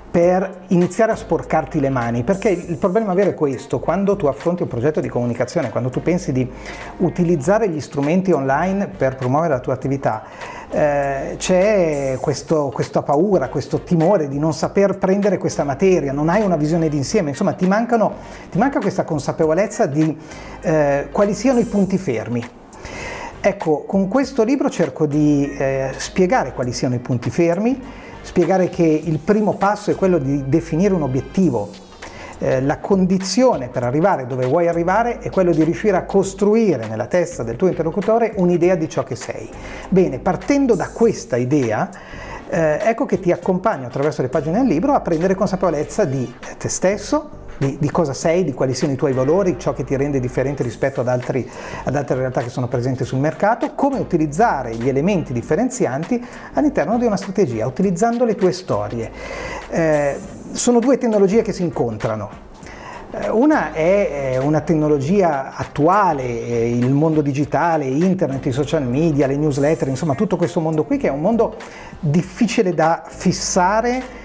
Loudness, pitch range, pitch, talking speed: -18 LUFS, 140-195 Hz, 165 Hz, 165 wpm